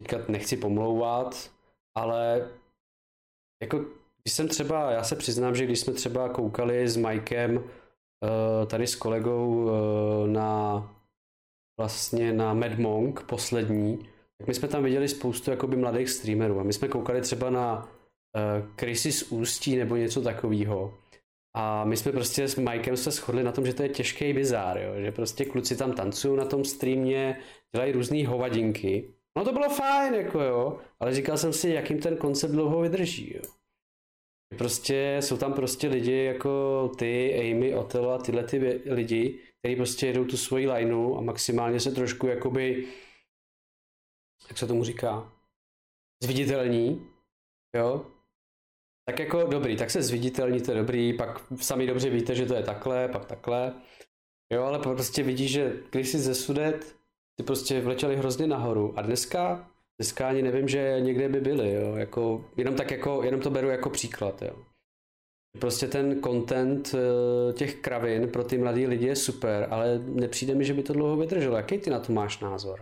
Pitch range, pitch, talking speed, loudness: 115-135 Hz, 125 Hz, 165 wpm, -28 LUFS